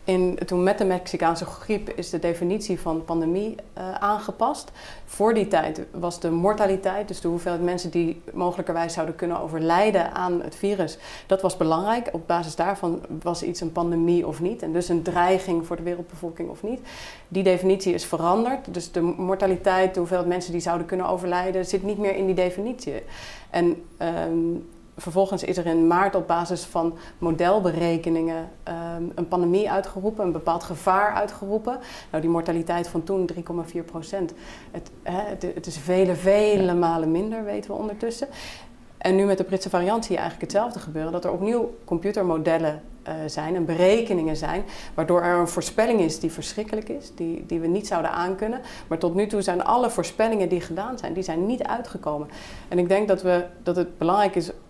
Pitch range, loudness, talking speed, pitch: 170-195 Hz, -24 LUFS, 180 wpm, 180 Hz